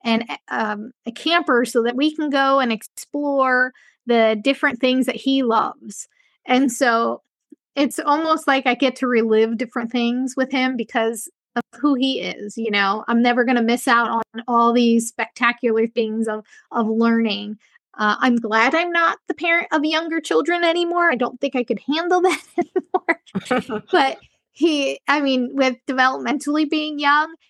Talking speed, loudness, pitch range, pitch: 170 wpm, -19 LUFS, 230-290 Hz, 255 Hz